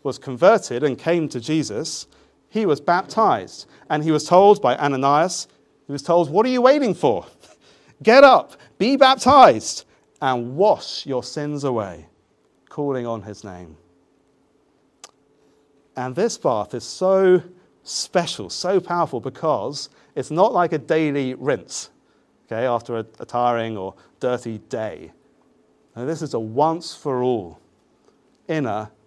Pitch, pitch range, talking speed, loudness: 140 Hz, 120-170 Hz, 130 wpm, -19 LUFS